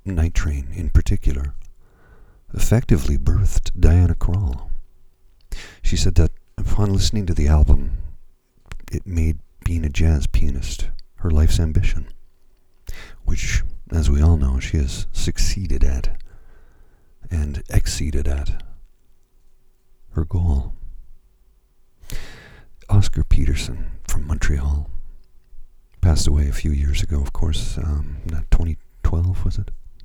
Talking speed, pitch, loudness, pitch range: 110 wpm, 80 Hz, -22 LUFS, 75-90 Hz